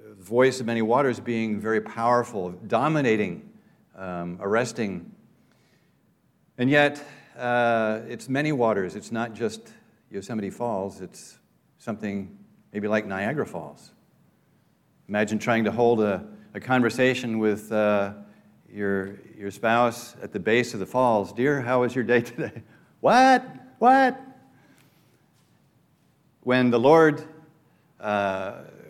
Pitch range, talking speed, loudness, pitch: 105-130 Hz, 120 wpm, -24 LUFS, 115 Hz